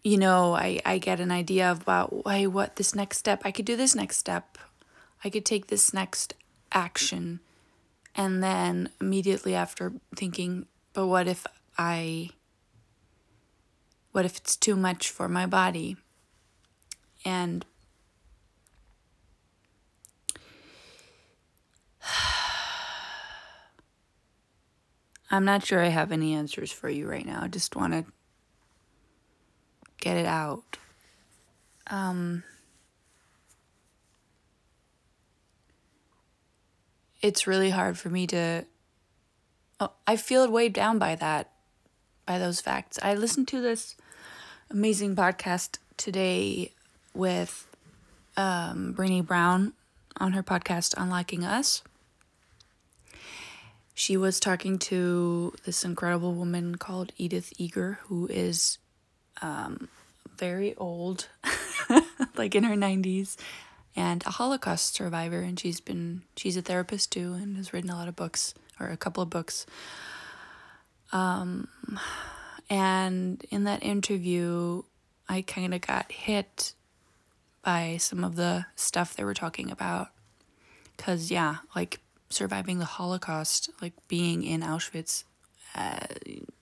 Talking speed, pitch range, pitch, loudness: 115 wpm, 160-195 Hz, 180 Hz, -29 LUFS